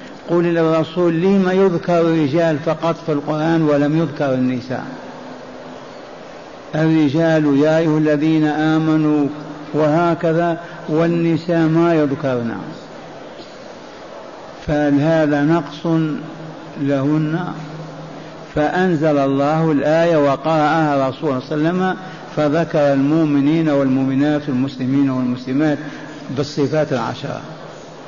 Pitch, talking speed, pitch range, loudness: 155 Hz, 85 wpm, 145-165 Hz, -17 LUFS